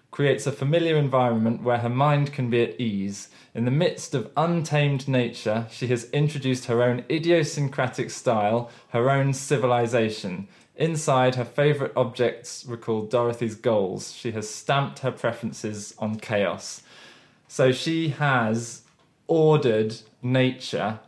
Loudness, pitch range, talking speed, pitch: -24 LUFS, 115-145 Hz, 130 wpm, 125 Hz